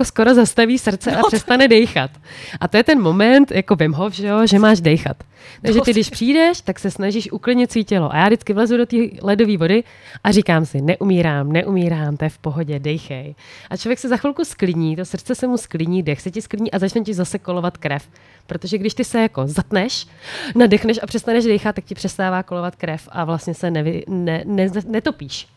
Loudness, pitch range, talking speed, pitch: -17 LUFS, 170-225 Hz, 210 wpm, 200 Hz